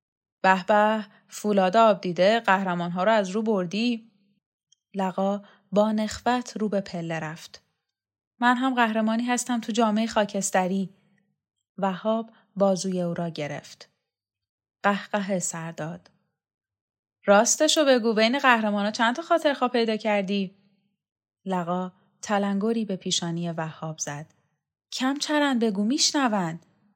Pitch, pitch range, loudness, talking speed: 200 Hz, 170-225 Hz, -24 LUFS, 120 wpm